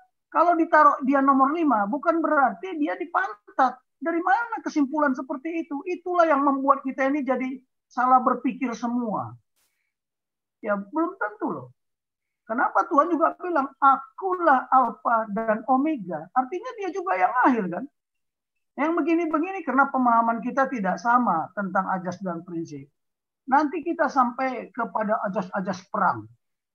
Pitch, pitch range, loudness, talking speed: 270 Hz, 230-320 Hz, -24 LUFS, 130 wpm